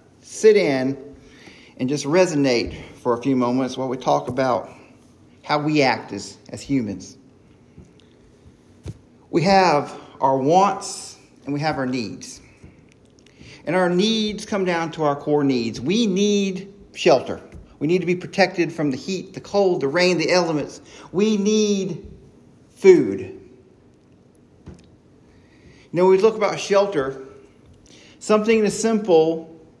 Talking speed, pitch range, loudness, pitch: 135 wpm, 140-195 Hz, -20 LUFS, 165 Hz